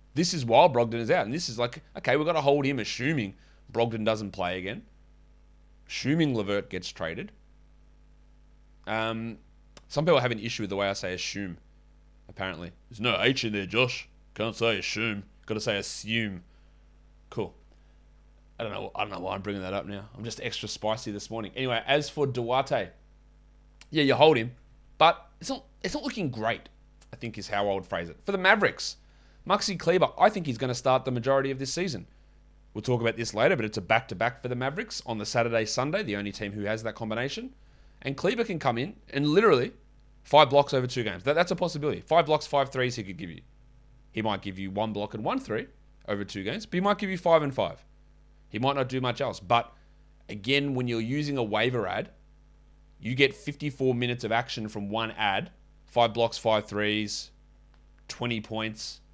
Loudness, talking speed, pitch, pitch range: -28 LUFS, 210 wpm, 120 Hz, 105-140 Hz